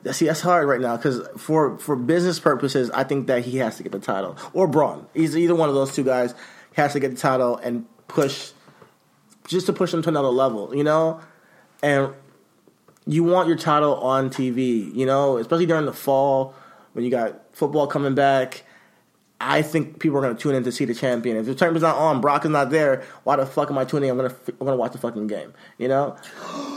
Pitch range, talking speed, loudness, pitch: 130-160 Hz, 235 wpm, -22 LUFS, 140 Hz